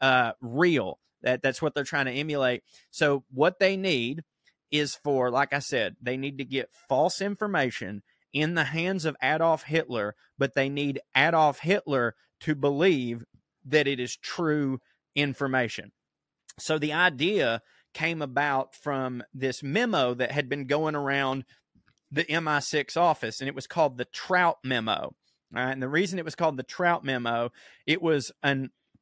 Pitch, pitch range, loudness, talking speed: 140 Hz, 130-155 Hz, -27 LUFS, 165 wpm